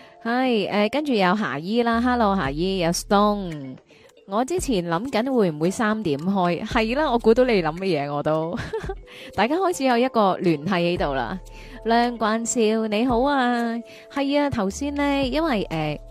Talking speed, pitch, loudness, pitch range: 265 characters per minute, 220 Hz, -22 LUFS, 180-245 Hz